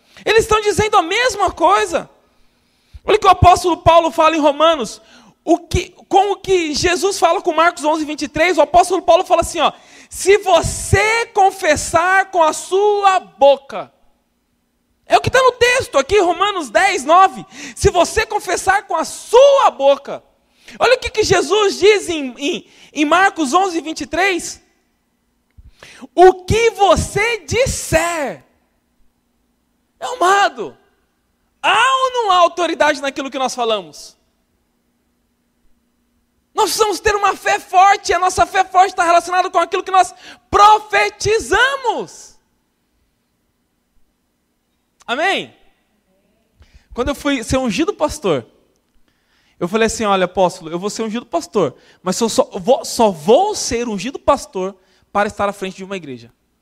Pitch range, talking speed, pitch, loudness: 265-390 Hz, 140 wpm, 340 Hz, -15 LUFS